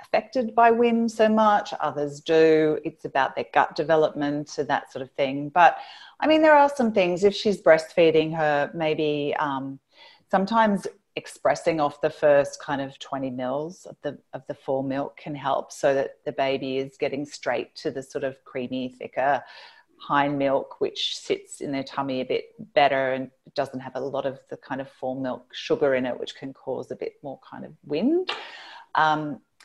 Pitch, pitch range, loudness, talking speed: 150 Hz, 135-205 Hz, -24 LUFS, 190 wpm